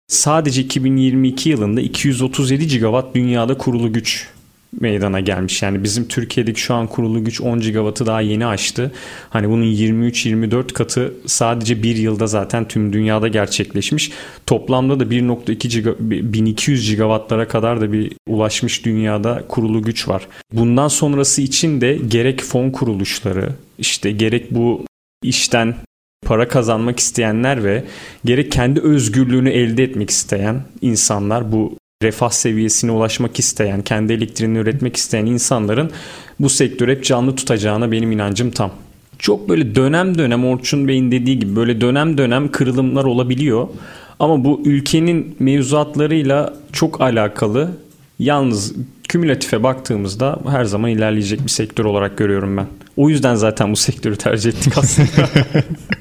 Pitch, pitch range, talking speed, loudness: 120 Hz, 110-135 Hz, 135 wpm, -16 LUFS